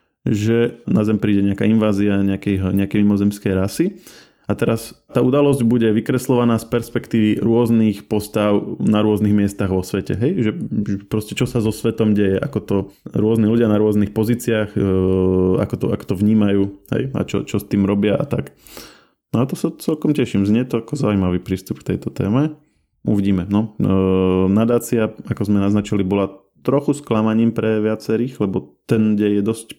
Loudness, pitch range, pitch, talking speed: -18 LUFS, 100-115 Hz, 105 Hz, 170 wpm